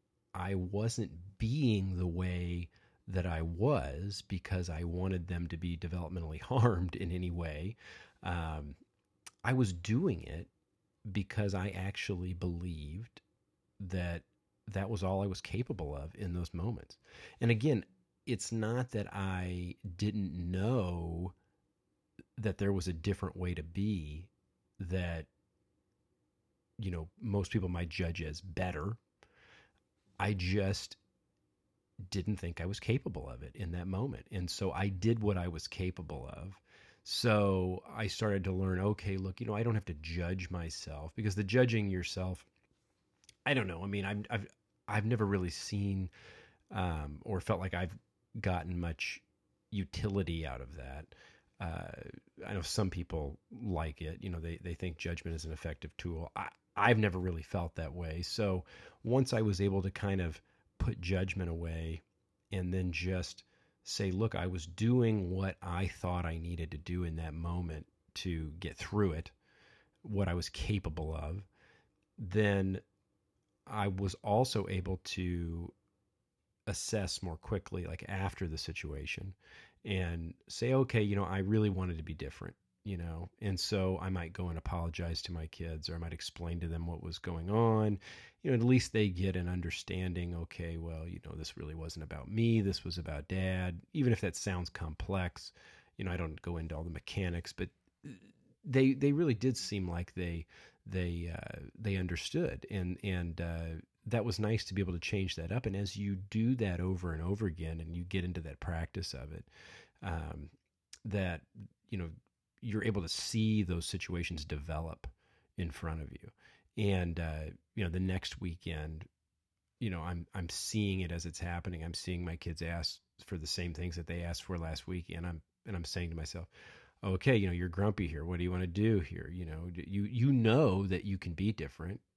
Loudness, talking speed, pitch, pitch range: -37 LUFS, 175 wpm, 90 Hz, 85-100 Hz